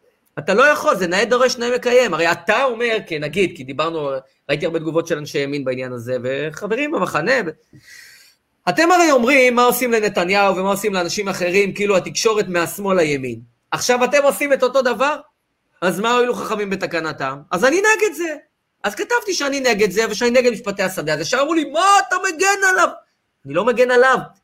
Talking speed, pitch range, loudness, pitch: 185 wpm, 170-270 Hz, -17 LUFS, 220 Hz